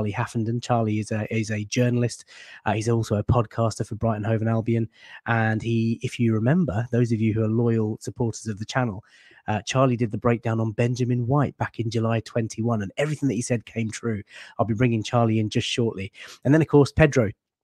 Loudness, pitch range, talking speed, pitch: -24 LUFS, 110-120 Hz, 215 wpm, 115 Hz